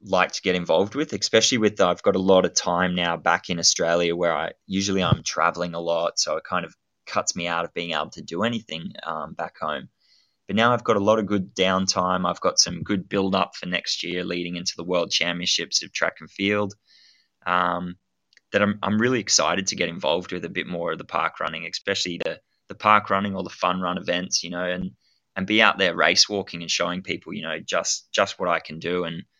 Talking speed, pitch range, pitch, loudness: 235 wpm, 85-100 Hz, 90 Hz, -23 LUFS